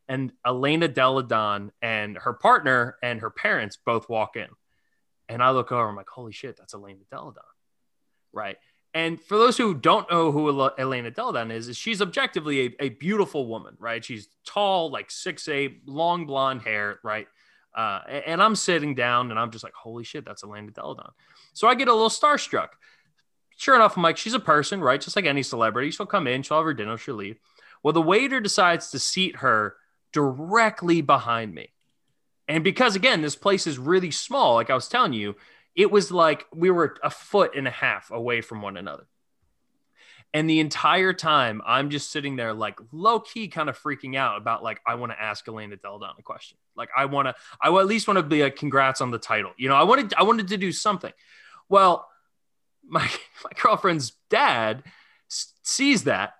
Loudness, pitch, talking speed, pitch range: -23 LUFS, 150 Hz, 195 wpm, 120-190 Hz